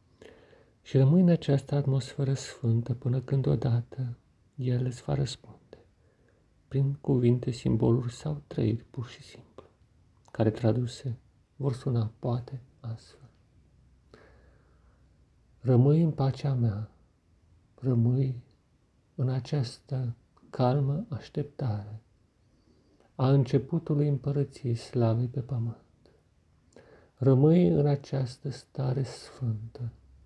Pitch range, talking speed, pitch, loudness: 115-140 Hz, 95 wpm, 125 Hz, -29 LUFS